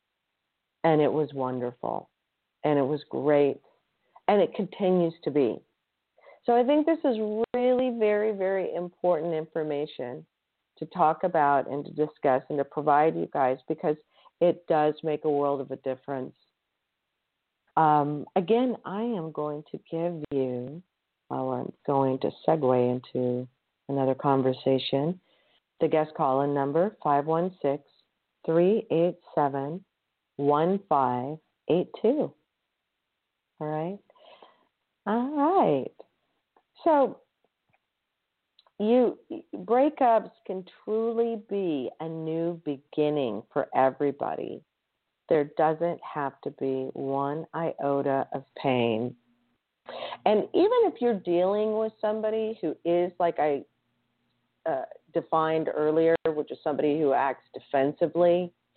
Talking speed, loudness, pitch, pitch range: 115 wpm, -27 LUFS, 155 Hz, 140-185 Hz